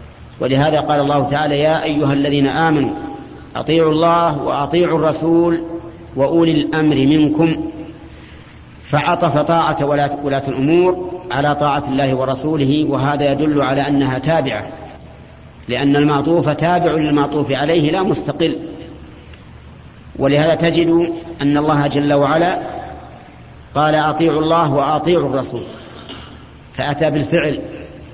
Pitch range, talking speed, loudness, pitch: 140-165 Hz, 100 wpm, -16 LUFS, 150 Hz